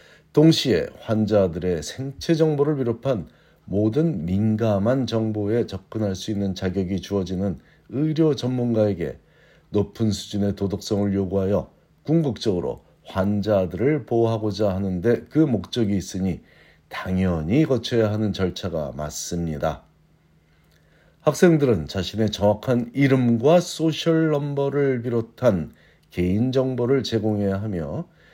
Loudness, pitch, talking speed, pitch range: -23 LUFS, 110 Hz, 270 characters per minute, 95-135 Hz